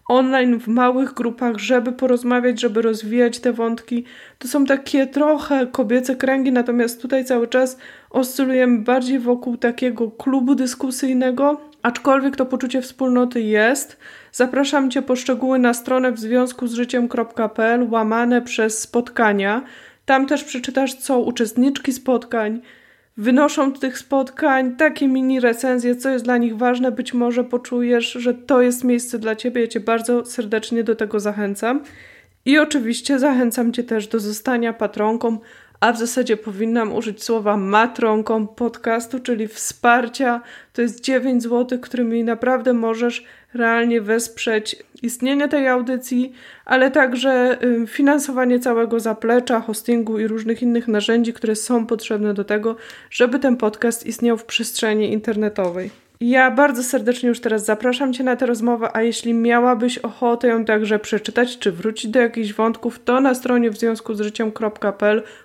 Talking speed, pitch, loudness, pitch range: 145 wpm, 245 Hz, -19 LUFS, 230-255 Hz